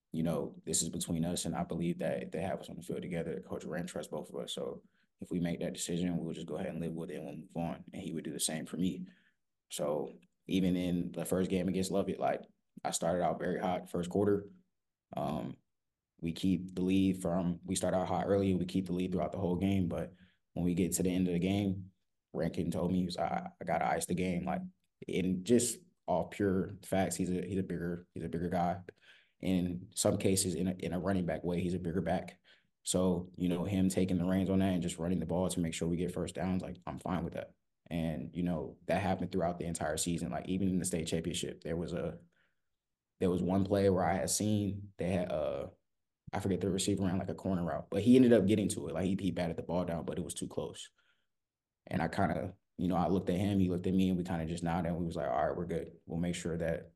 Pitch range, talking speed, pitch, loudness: 85-95 Hz, 265 wpm, 90 Hz, -34 LUFS